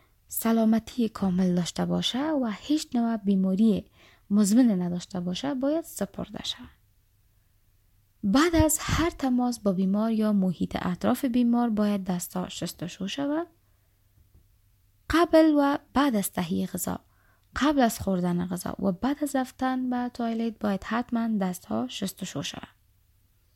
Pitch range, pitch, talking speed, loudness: 170-245 Hz, 200 Hz, 130 wpm, -26 LUFS